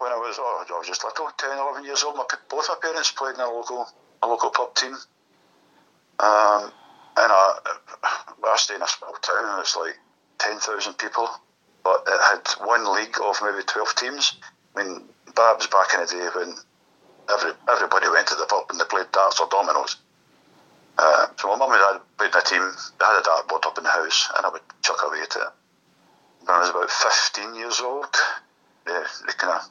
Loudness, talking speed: -22 LUFS, 210 wpm